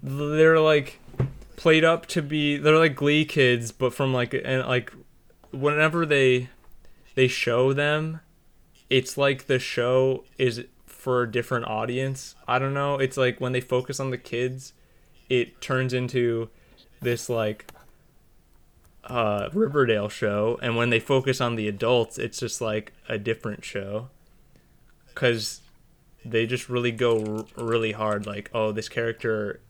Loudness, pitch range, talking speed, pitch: -24 LUFS, 115-140 Hz, 150 wpm, 125 Hz